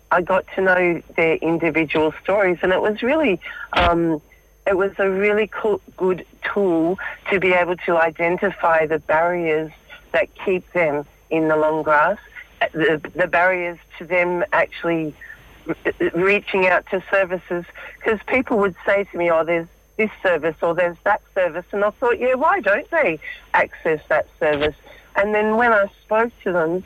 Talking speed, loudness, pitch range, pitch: 170 wpm, -20 LUFS, 165-205 Hz, 180 Hz